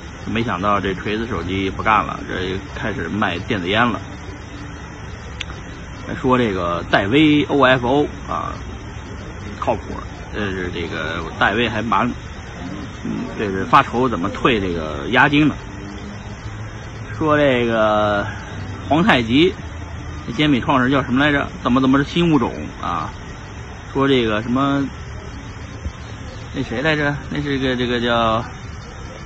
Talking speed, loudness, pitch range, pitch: 190 characters per minute, -18 LUFS, 100-130 Hz, 110 Hz